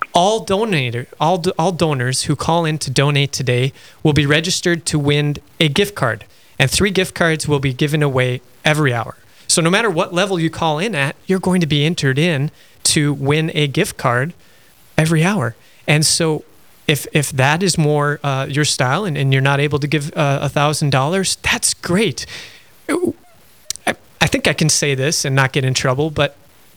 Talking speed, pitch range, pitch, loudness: 195 wpm, 140-165 Hz, 150 Hz, -17 LUFS